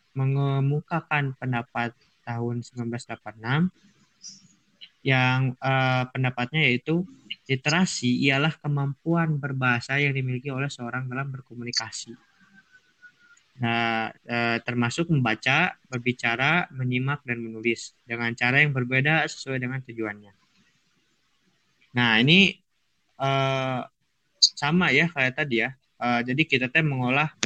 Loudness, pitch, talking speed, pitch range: -24 LUFS, 130 Hz, 100 wpm, 120-150 Hz